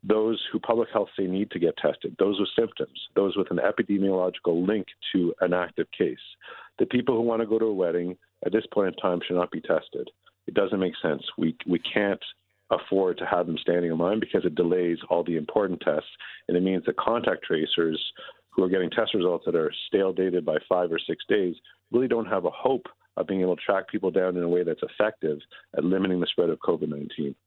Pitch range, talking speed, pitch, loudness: 90-105 Hz, 225 wpm, 95 Hz, -26 LUFS